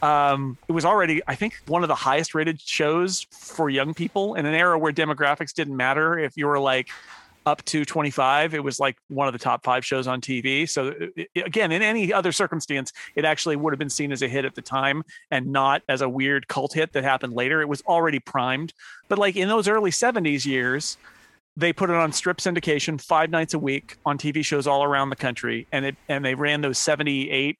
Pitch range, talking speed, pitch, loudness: 135-165 Hz, 230 wpm, 150 Hz, -23 LUFS